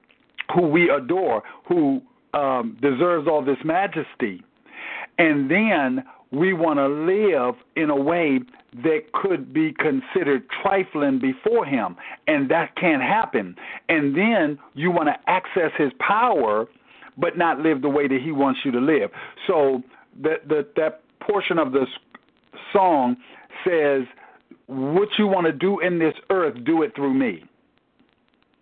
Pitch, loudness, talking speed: 160 Hz, -22 LUFS, 145 wpm